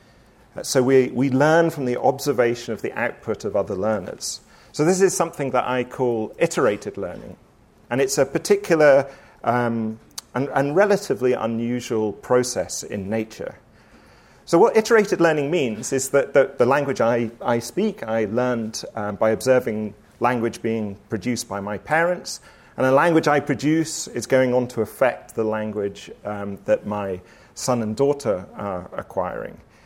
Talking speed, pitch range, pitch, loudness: 155 wpm, 110-140 Hz, 125 Hz, -21 LUFS